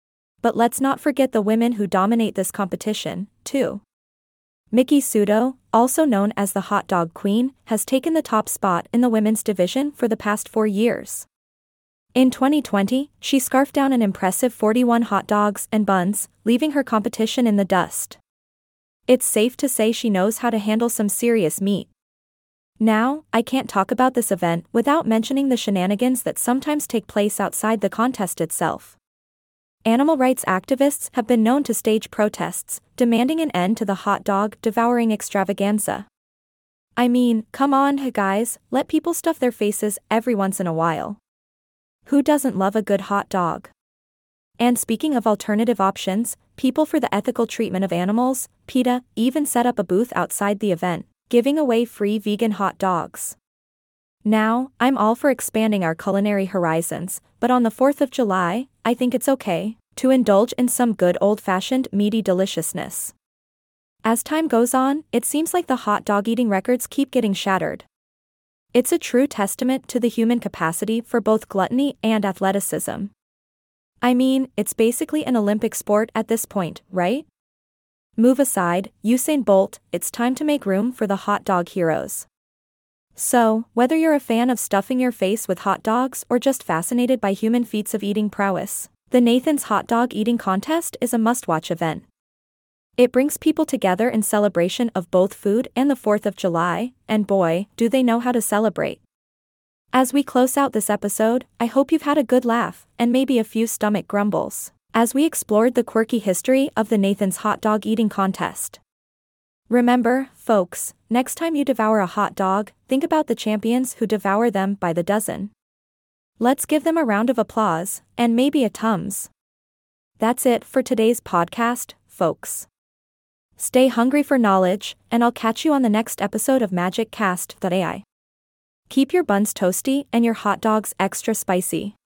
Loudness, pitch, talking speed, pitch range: -20 LUFS, 225 Hz, 170 wpm, 200-250 Hz